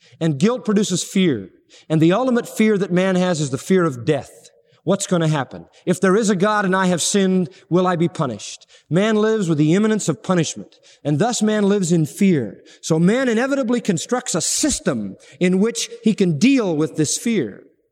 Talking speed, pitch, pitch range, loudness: 200 wpm, 185 Hz, 160-215 Hz, -19 LUFS